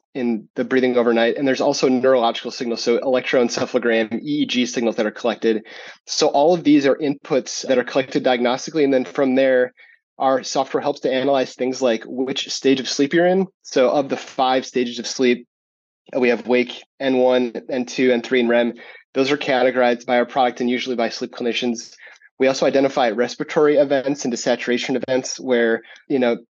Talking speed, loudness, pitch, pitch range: 185 wpm, -19 LUFS, 125 Hz, 120-135 Hz